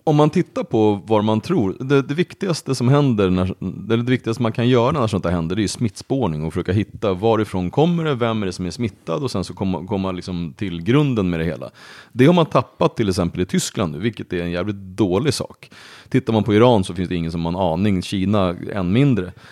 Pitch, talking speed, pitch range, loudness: 105 Hz, 245 wpm, 90-125 Hz, -20 LUFS